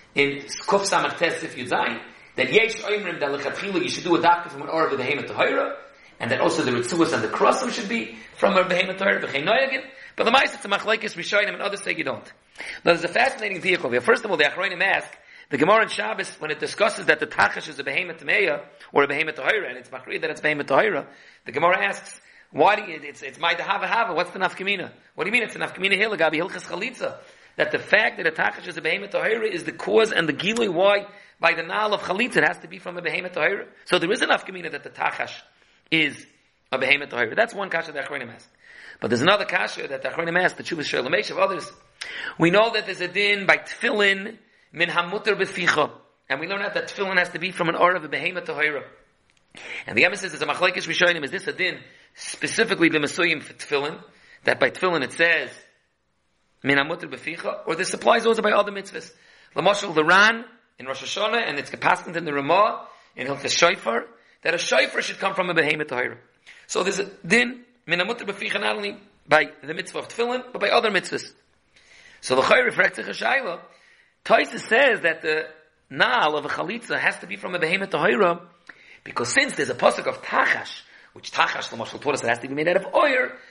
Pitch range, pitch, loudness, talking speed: 165-210 Hz, 185 Hz, -22 LUFS, 220 wpm